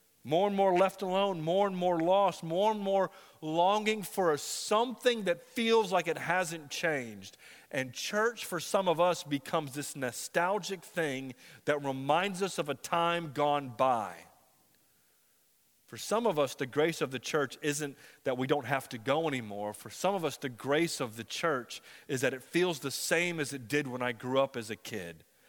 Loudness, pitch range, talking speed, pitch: -32 LUFS, 135-185 Hz, 195 wpm, 160 Hz